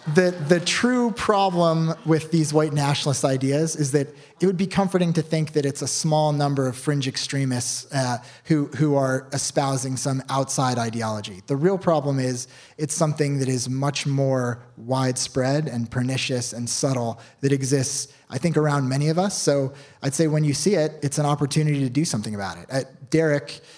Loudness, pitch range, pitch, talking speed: -23 LUFS, 130-155 Hz, 145 Hz, 185 wpm